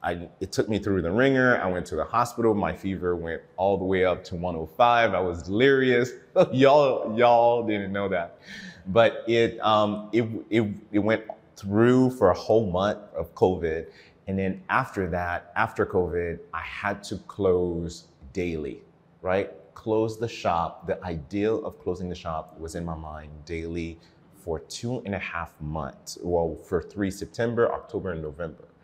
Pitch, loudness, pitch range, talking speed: 95 Hz, -25 LUFS, 85-115 Hz, 170 wpm